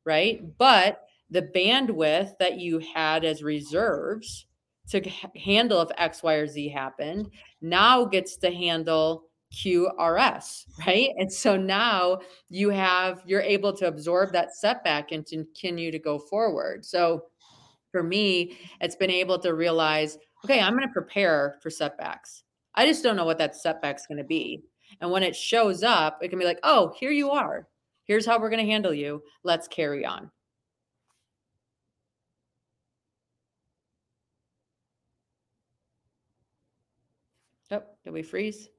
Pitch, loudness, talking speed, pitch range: 175 Hz, -25 LUFS, 145 wpm, 155-200 Hz